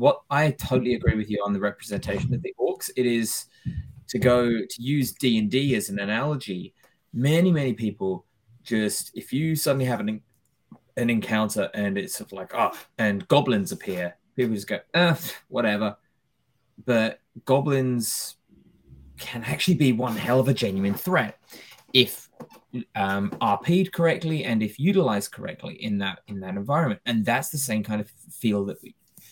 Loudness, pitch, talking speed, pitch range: -25 LUFS, 120 Hz, 170 wpm, 105-140 Hz